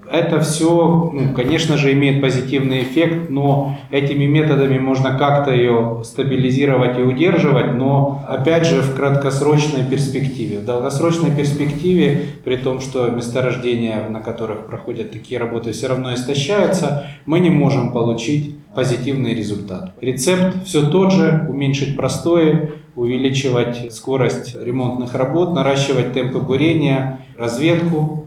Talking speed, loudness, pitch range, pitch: 125 wpm, -17 LUFS, 125-150 Hz, 135 Hz